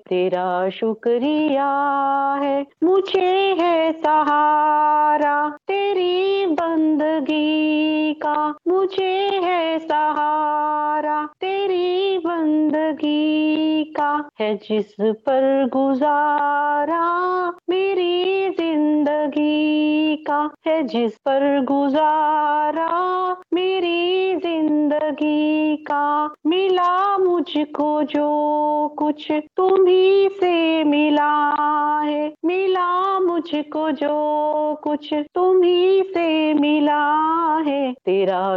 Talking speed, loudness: 70 wpm, -19 LUFS